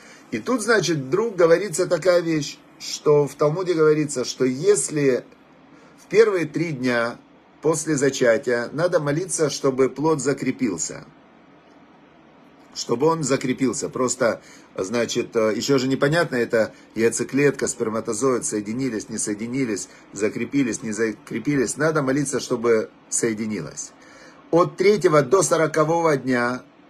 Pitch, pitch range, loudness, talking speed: 140 Hz, 120-165 Hz, -21 LUFS, 110 wpm